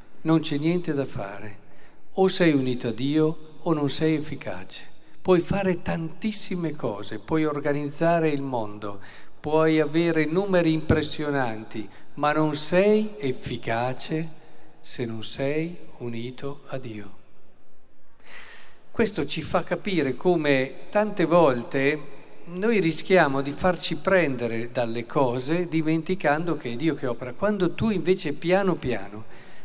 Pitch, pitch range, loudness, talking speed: 150 Hz, 125-170 Hz, -25 LUFS, 125 wpm